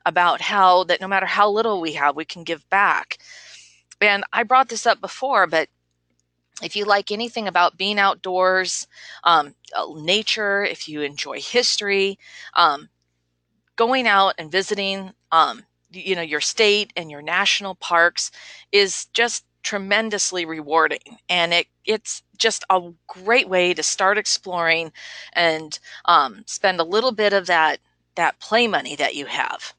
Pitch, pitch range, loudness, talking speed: 190 Hz, 165-210 Hz, -20 LUFS, 150 wpm